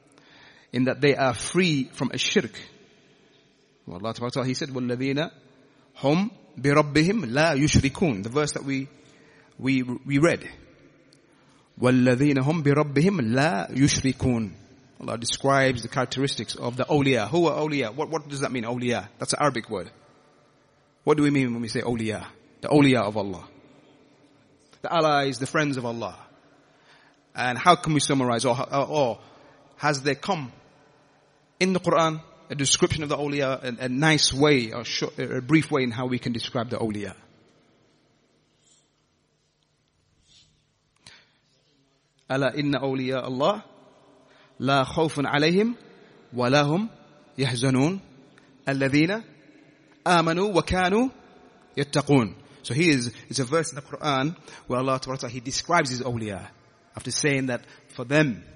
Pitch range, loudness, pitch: 125-150 Hz, -24 LUFS, 140 Hz